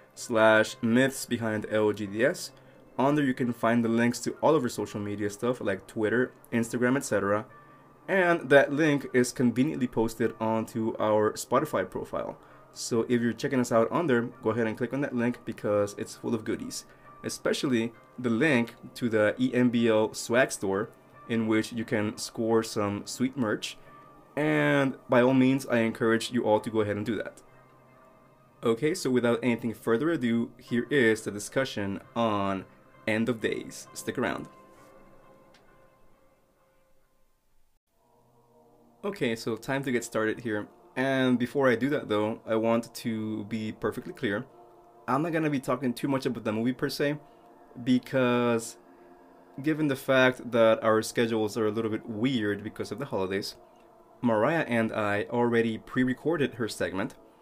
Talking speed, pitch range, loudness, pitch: 160 wpm, 110-130 Hz, -28 LUFS, 115 Hz